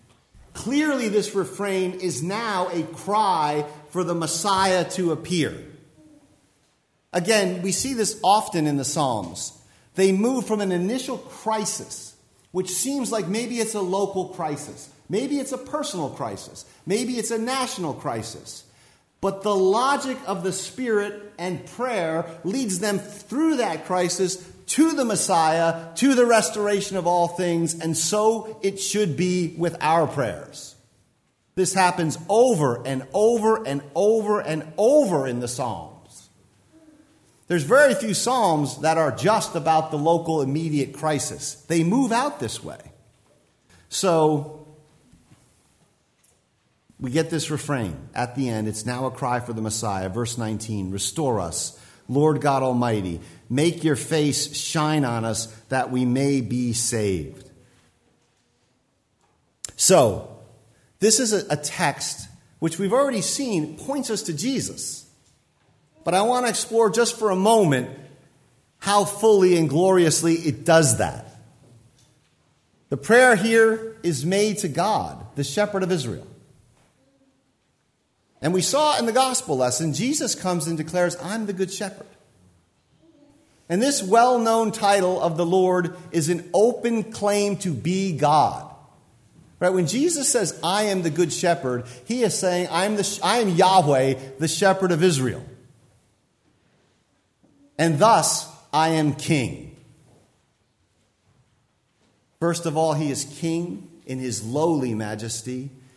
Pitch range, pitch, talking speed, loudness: 135-205 Hz, 165 Hz, 135 wpm, -22 LUFS